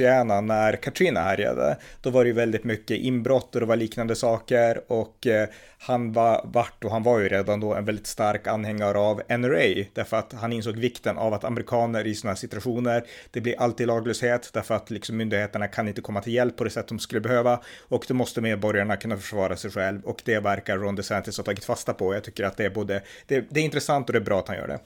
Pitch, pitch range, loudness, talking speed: 115 Hz, 105-120 Hz, -25 LUFS, 235 wpm